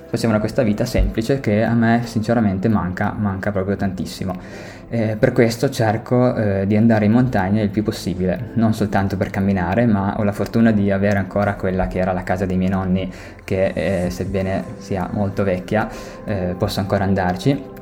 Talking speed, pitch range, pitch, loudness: 180 wpm, 95-110 Hz, 100 Hz, -19 LUFS